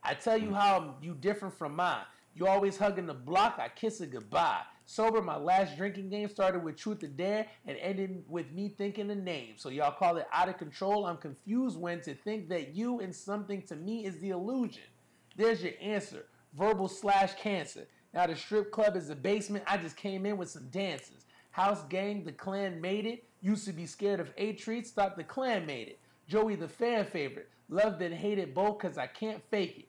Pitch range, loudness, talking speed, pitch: 175-210 Hz, -34 LUFS, 215 wpm, 195 Hz